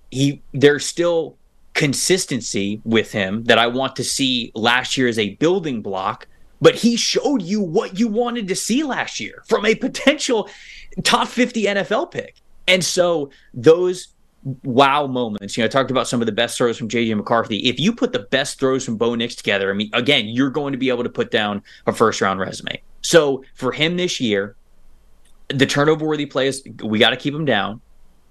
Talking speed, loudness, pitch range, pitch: 195 wpm, -19 LUFS, 120-185 Hz, 135 Hz